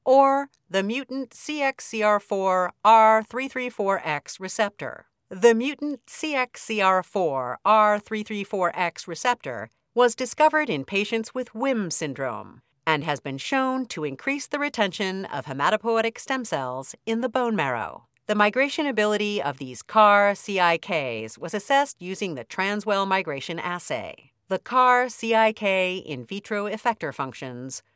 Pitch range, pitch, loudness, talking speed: 180-245 Hz, 210 Hz, -24 LUFS, 115 wpm